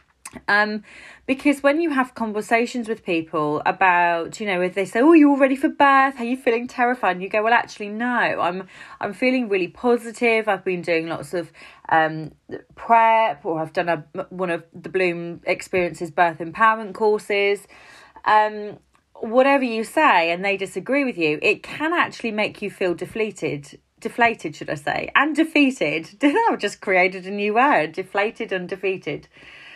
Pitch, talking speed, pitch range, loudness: 205 Hz, 170 wpm, 180-240 Hz, -20 LUFS